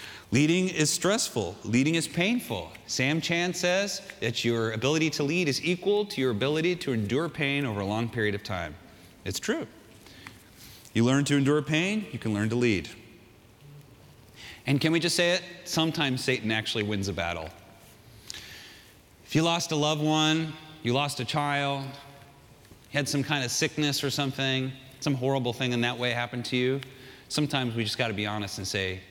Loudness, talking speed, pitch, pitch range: -27 LUFS, 180 wpm, 130 Hz, 110-150 Hz